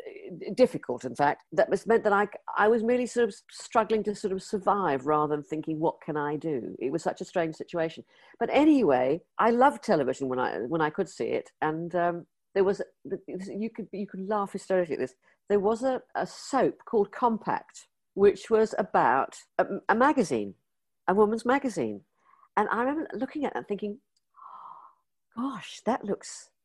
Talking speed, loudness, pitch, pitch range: 185 wpm, -28 LUFS, 205 Hz, 170-235 Hz